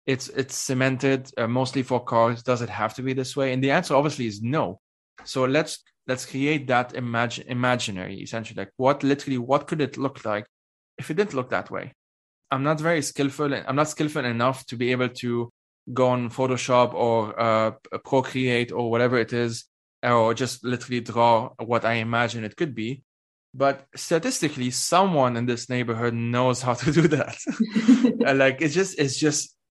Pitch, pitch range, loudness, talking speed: 130 Hz, 120-140 Hz, -24 LUFS, 180 wpm